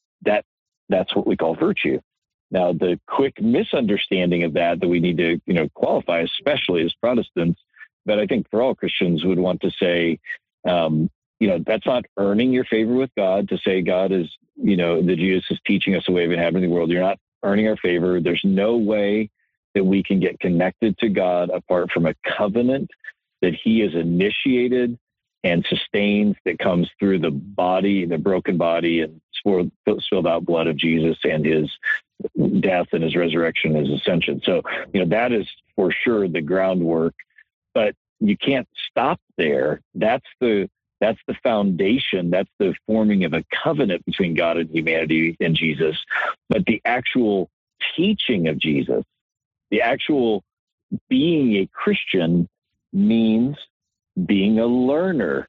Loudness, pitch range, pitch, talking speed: -20 LUFS, 85-110 Hz, 90 Hz, 170 wpm